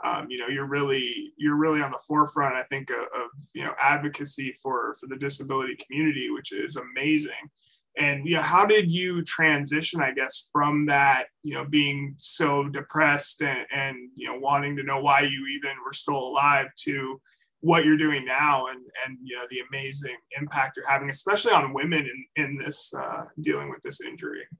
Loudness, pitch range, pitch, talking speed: -25 LUFS, 135-155 Hz, 145 Hz, 195 wpm